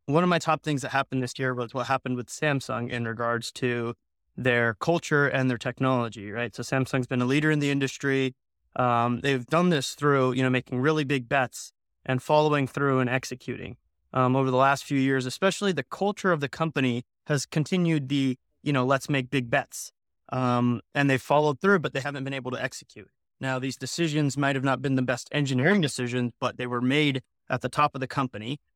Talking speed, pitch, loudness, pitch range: 210 wpm, 135 Hz, -26 LUFS, 125-145 Hz